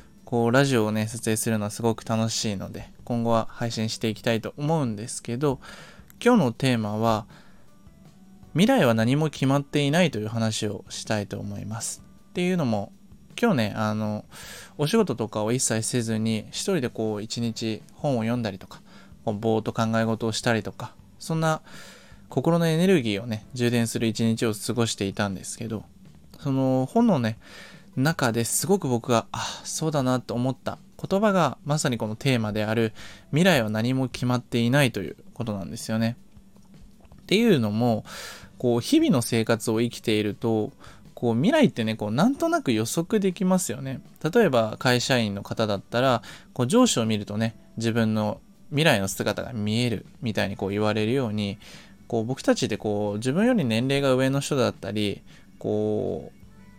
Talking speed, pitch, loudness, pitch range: 340 characters per minute, 115 Hz, -25 LUFS, 110-140 Hz